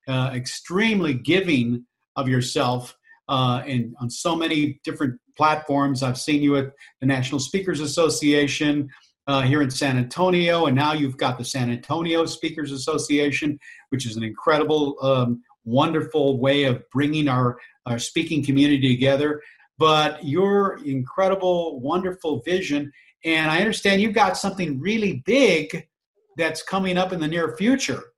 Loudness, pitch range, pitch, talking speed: -22 LUFS, 135-165 Hz, 150 Hz, 145 wpm